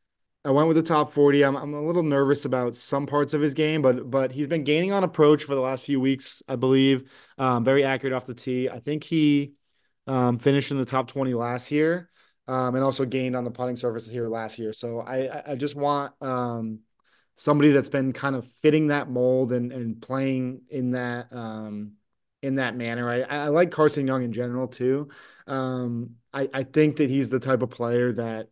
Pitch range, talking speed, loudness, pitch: 125-145 Hz, 215 wpm, -25 LUFS, 130 Hz